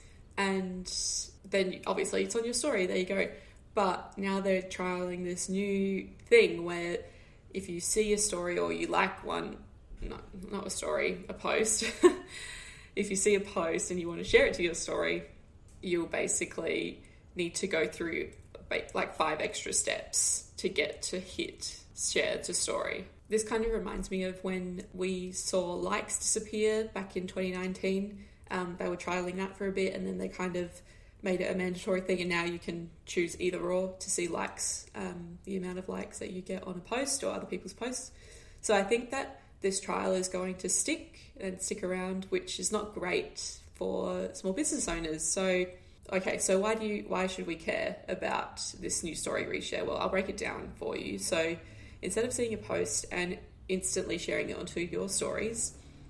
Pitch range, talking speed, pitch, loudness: 180-200 Hz, 190 wpm, 185 Hz, -33 LUFS